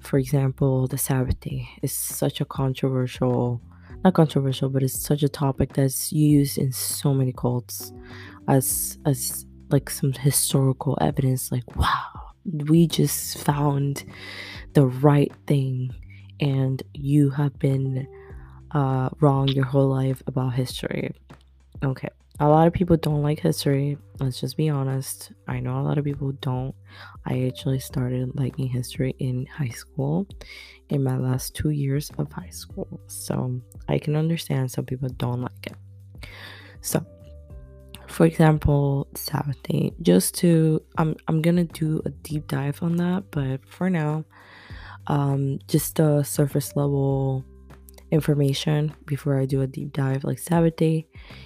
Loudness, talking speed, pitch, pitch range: -24 LUFS, 145 wpm, 135 Hz, 105-145 Hz